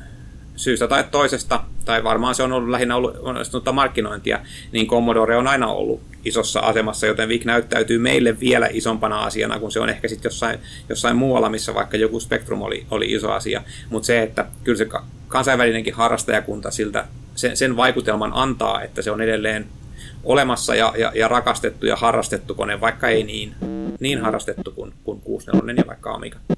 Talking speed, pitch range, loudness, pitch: 175 wpm, 110-125 Hz, -20 LUFS, 115 Hz